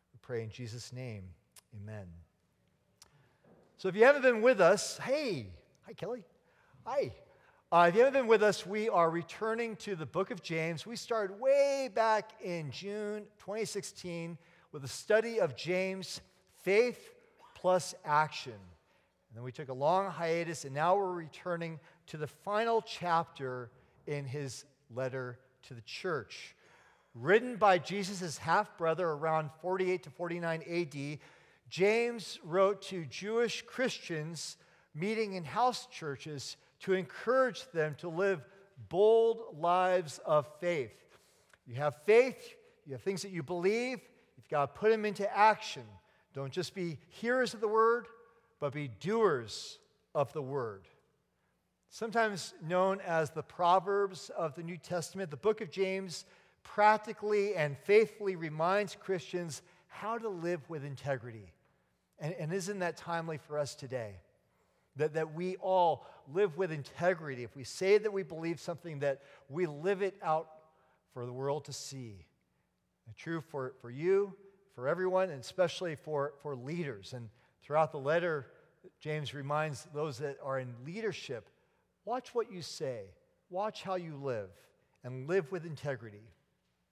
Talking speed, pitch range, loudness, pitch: 150 wpm, 145-200 Hz, -34 LUFS, 170 Hz